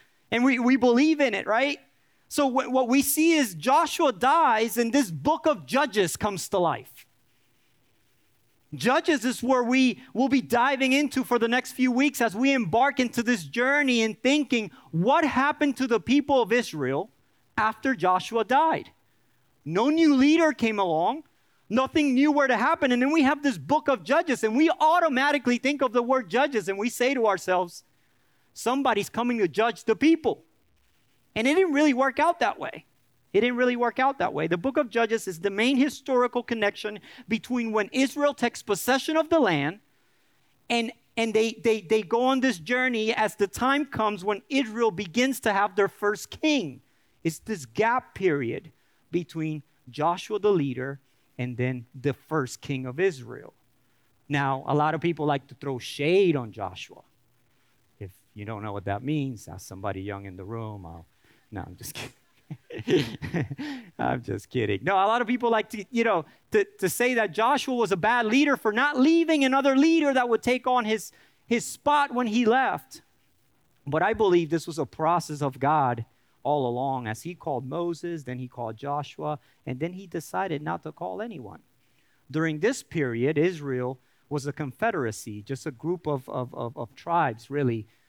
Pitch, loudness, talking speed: 220 Hz, -25 LUFS, 180 wpm